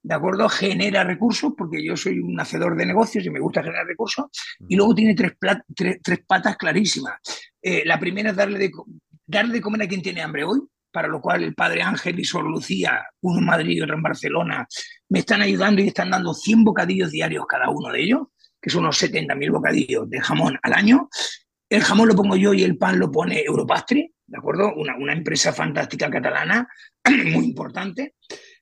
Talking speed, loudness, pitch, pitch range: 205 wpm, -20 LUFS, 205 Hz, 185-250 Hz